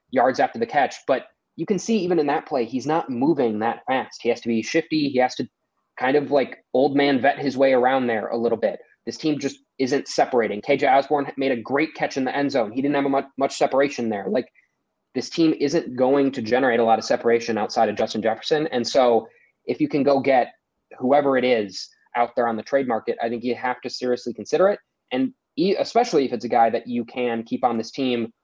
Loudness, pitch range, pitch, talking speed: -22 LUFS, 115-145 Hz, 135 Hz, 240 wpm